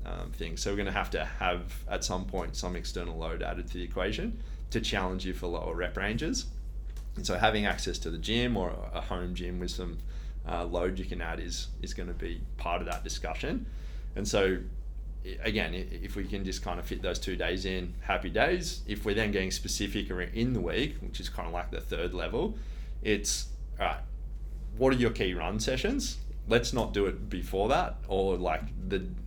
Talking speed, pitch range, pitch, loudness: 210 wpm, 85-100 Hz, 90 Hz, -33 LUFS